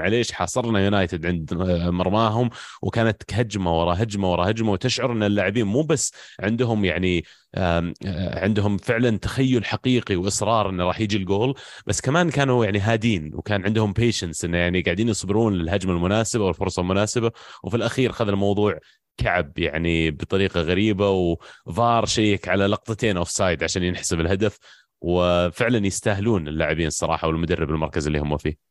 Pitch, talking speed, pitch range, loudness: 100 Hz, 145 wpm, 90-110 Hz, -22 LUFS